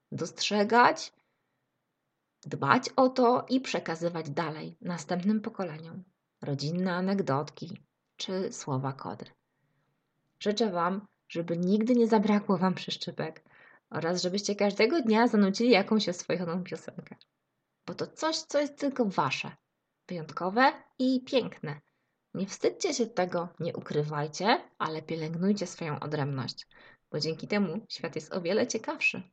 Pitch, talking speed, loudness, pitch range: 185 Hz, 120 wpm, -29 LUFS, 165-230 Hz